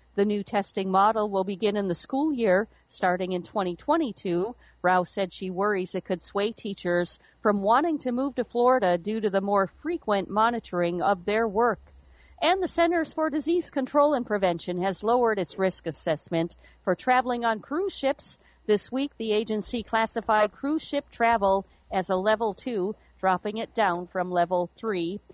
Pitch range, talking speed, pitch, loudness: 185-245 Hz, 170 wpm, 210 Hz, -26 LUFS